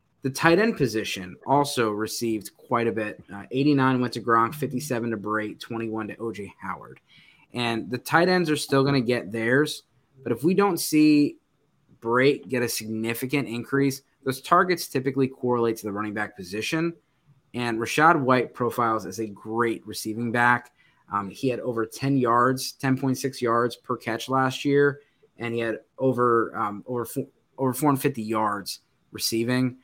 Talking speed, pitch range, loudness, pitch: 165 wpm, 115-135 Hz, -25 LUFS, 125 Hz